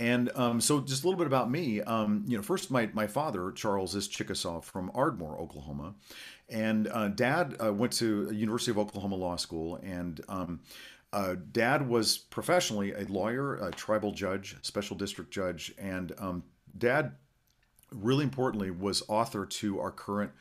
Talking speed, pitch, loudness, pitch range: 170 wpm, 105 Hz, -32 LUFS, 95-120 Hz